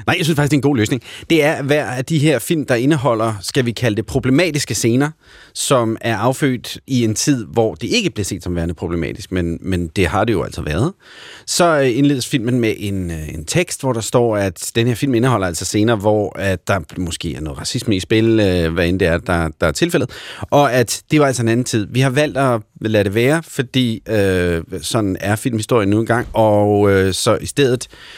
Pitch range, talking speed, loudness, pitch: 95-135 Hz, 230 wpm, -17 LUFS, 115 Hz